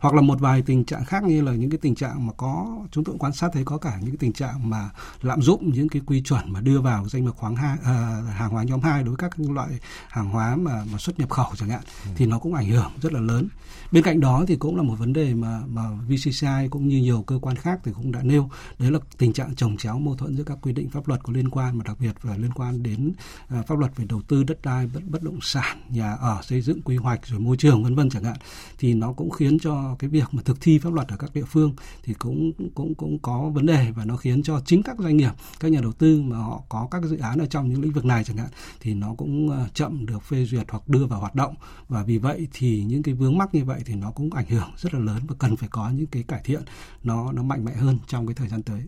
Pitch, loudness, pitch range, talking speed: 130 Hz, -24 LUFS, 115-150 Hz, 285 wpm